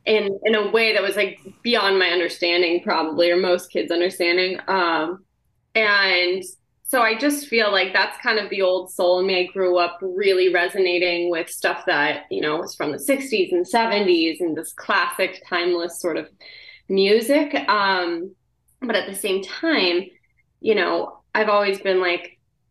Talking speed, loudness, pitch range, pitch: 170 wpm, -20 LUFS, 175-205 Hz, 185 Hz